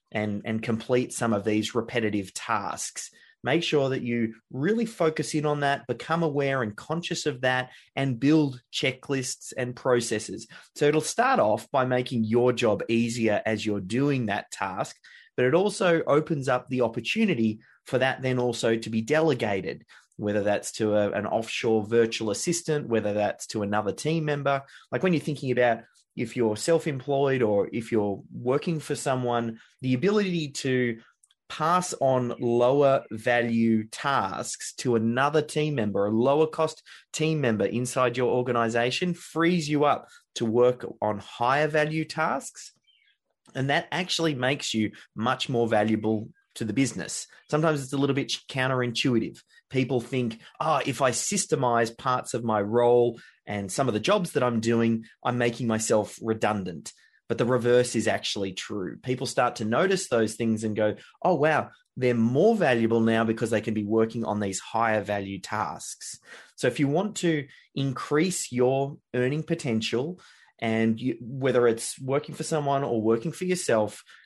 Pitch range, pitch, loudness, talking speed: 115-145 Hz, 125 Hz, -26 LUFS, 165 wpm